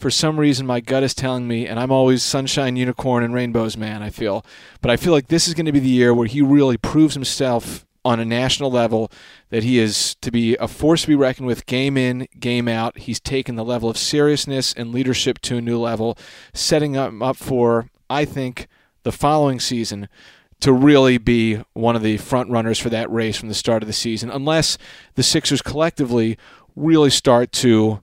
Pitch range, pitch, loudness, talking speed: 115-135 Hz, 125 Hz, -18 LUFS, 210 wpm